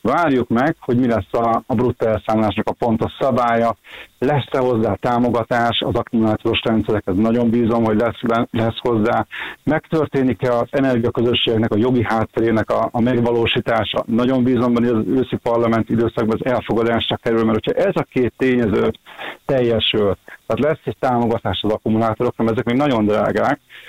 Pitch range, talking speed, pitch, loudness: 110-125 Hz, 150 wpm, 115 Hz, -18 LUFS